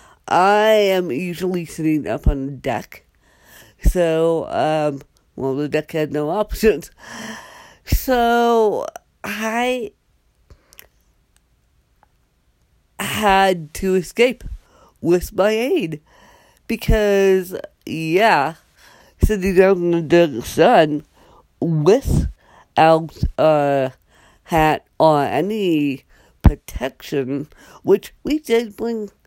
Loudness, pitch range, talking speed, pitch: -18 LUFS, 155-215 Hz, 85 wpm, 175 Hz